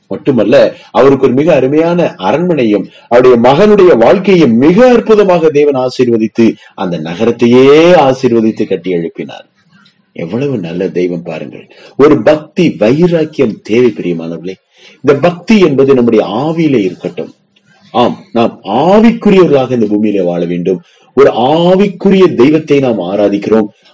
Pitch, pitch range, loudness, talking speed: 130 Hz, 110-175 Hz, -9 LUFS, 105 wpm